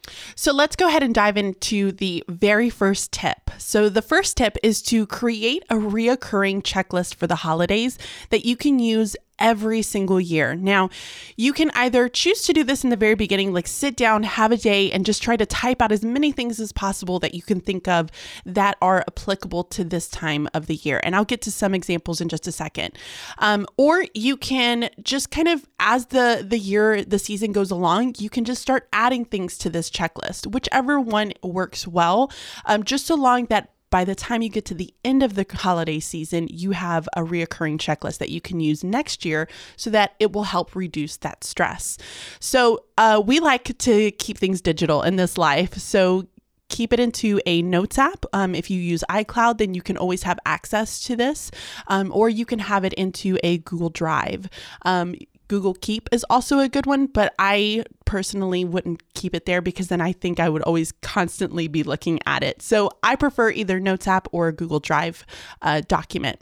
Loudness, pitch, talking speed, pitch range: -21 LUFS, 200 Hz, 205 wpm, 180-235 Hz